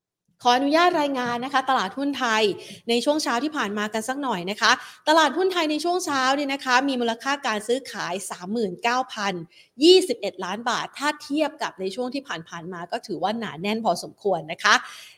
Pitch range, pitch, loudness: 205-280 Hz, 245 Hz, -23 LUFS